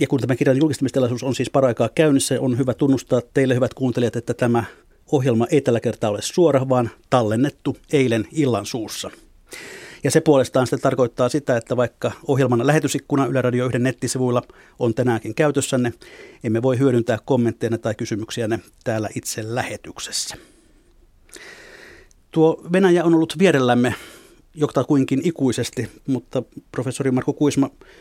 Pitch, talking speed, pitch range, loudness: 130 Hz, 140 wpm, 120-145 Hz, -20 LUFS